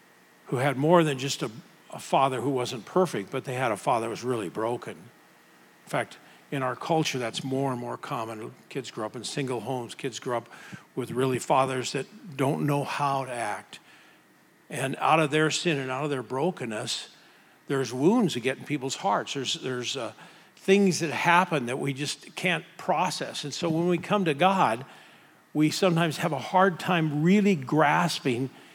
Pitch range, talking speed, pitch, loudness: 130-170 Hz, 190 wpm, 140 Hz, -27 LUFS